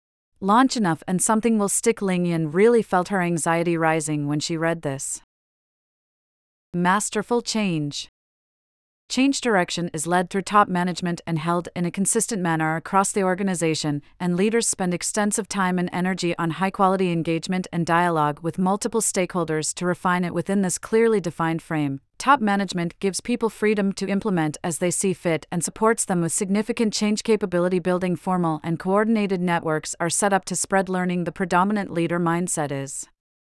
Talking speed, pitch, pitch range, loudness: 165 wpm, 180 Hz, 165-200 Hz, -22 LUFS